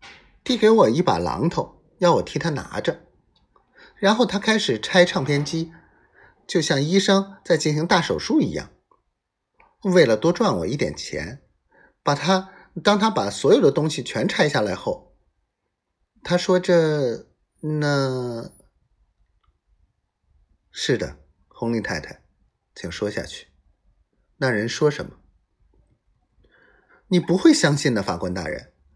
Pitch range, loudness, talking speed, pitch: 145-195 Hz, -21 LUFS, 180 characters per minute, 170 Hz